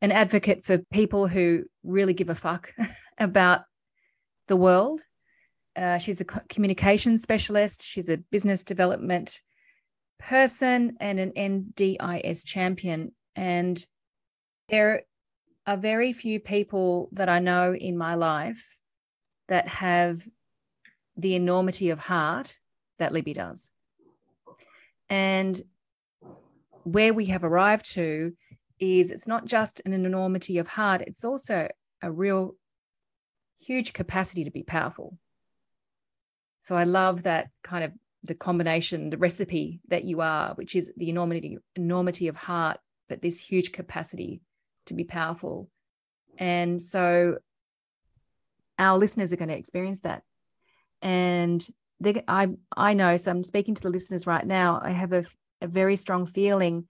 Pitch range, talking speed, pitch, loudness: 175-200 Hz, 135 wpm, 185 Hz, -26 LUFS